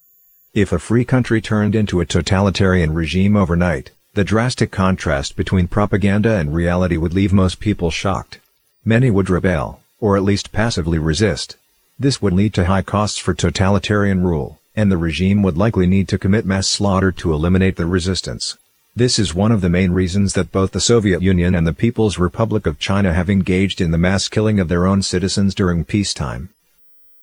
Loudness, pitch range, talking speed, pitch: -17 LUFS, 90-105 Hz, 185 wpm, 95 Hz